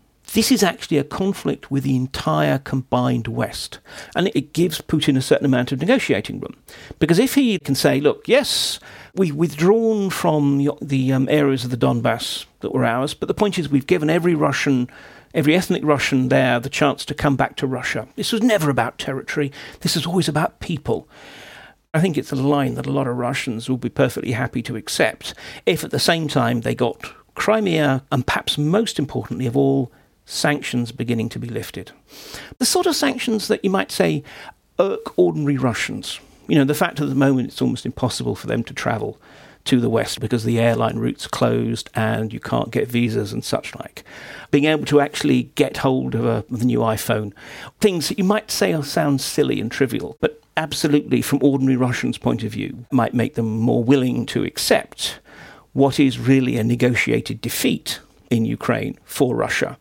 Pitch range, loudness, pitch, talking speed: 125-160 Hz, -20 LUFS, 140 Hz, 190 wpm